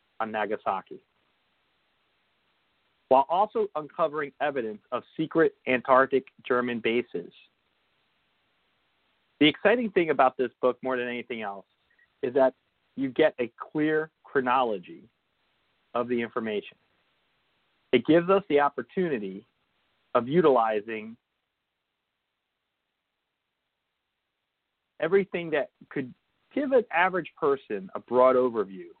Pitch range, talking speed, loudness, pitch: 120-160 Hz, 100 wpm, -26 LUFS, 130 Hz